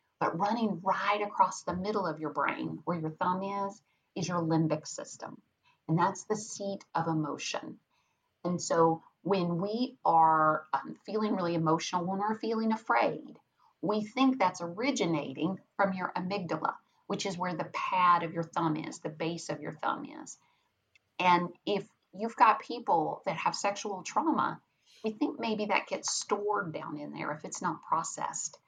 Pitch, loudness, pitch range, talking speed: 180 Hz, -31 LUFS, 165-205 Hz, 165 wpm